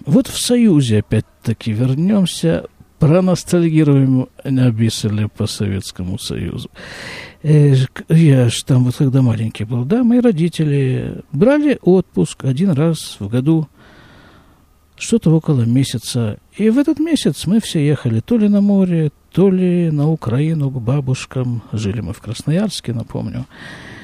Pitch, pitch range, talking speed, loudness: 145 Hz, 120-180 Hz, 130 wpm, -16 LUFS